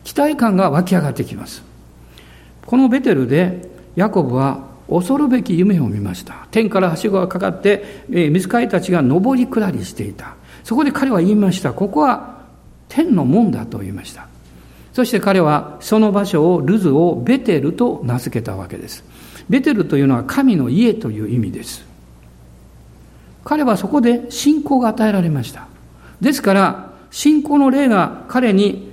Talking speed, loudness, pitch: 310 characters per minute, -16 LUFS, 185 Hz